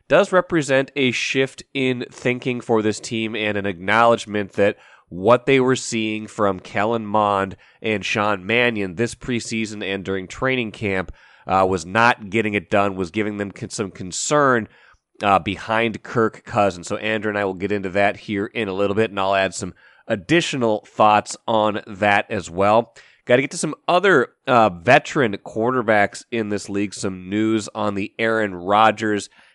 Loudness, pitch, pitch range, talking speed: -20 LUFS, 110 Hz, 100-115 Hz, 175 wpm